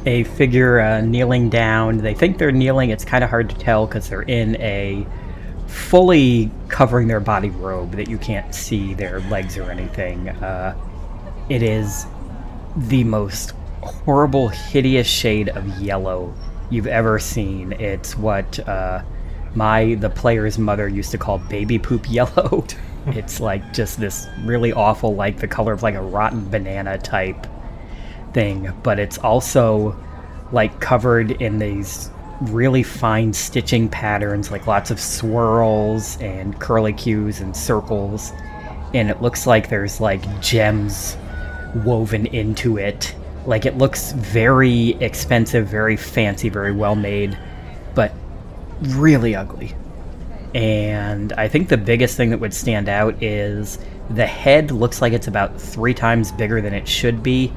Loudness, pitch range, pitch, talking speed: -19 LUFS, 95-115 Hz, 110 Hz, 145 wpm